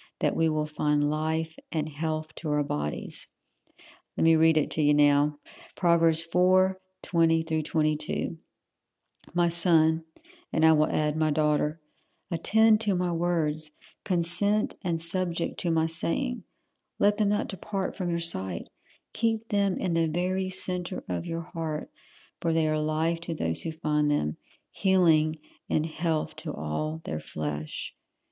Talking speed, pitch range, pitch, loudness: 155 wpm, 155-180 Hz, 160 Hz, -27 LUFS